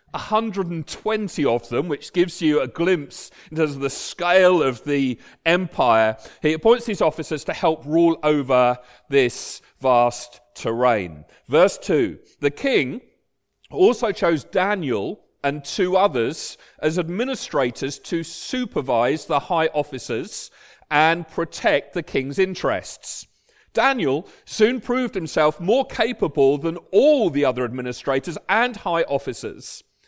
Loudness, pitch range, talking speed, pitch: -21 LUFS, 140-190 Hz, 125 wpm, 160 Hz